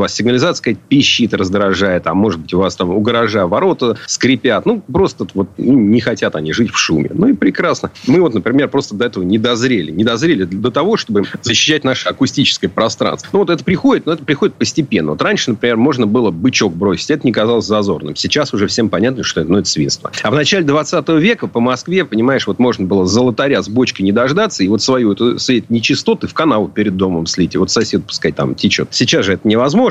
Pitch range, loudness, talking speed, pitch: 100-140 Hz, -14 LUFS, 215 wpm, 120 Hz